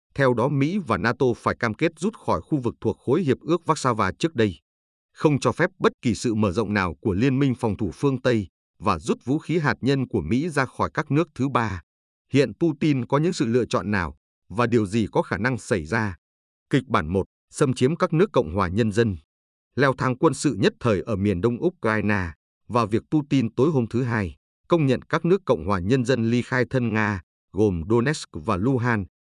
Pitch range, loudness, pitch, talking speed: 105-140 Hz, -23 LUFS, 120 Hz, 225 wpm